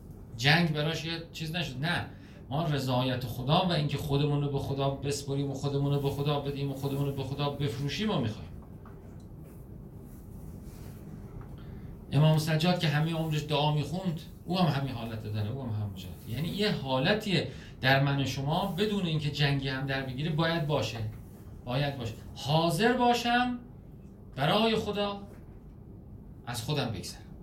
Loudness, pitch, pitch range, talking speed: -30 LUFS, 140 Hz, 130-165 Hz, 150 wpm